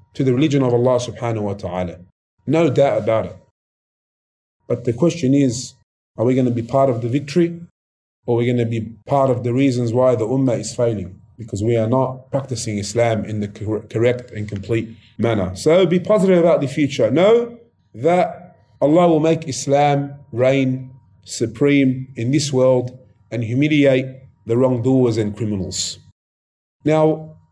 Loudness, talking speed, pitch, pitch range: -18 LUFS, 165 wpm, 125 Hz, 110-140 Hz